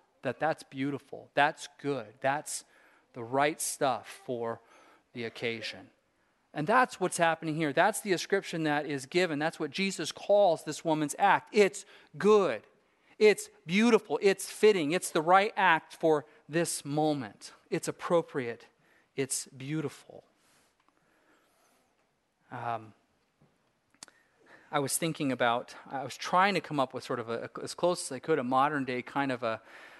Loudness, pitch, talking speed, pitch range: -30 LUFS, 150 Hz, 145 wpm, 135-175 Hz